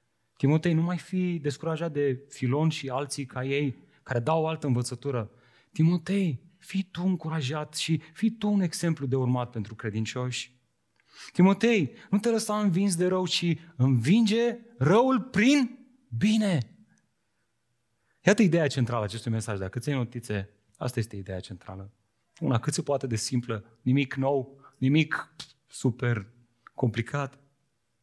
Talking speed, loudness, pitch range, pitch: 135 wpm, -27 LUFS, 120-175 Hz, 140 Hz